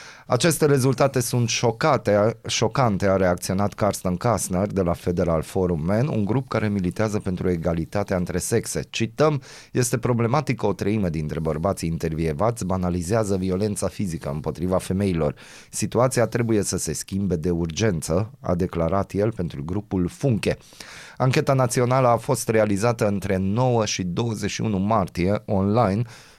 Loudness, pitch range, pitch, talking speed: -23 LUFS, 90-115 Hz, 100 Hz, 135 wpm